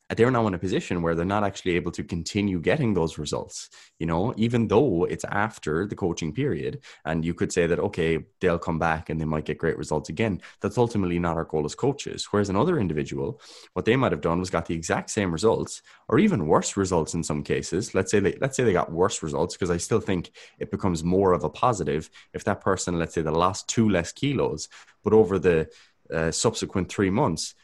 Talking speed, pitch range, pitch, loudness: 230 wpm, 80-100 Hz, 90 Hz, -25 LUFS